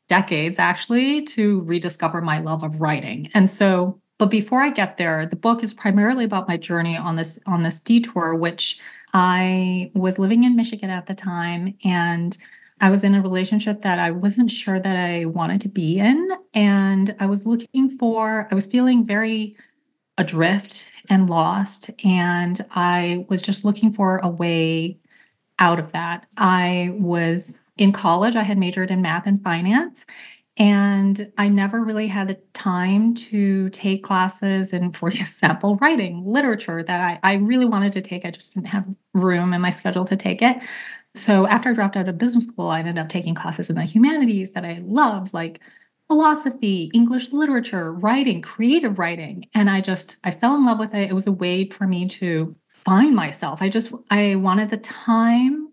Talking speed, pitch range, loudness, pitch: 180 wpm, 180-220 Hz, -20 LUFS, 195 Hz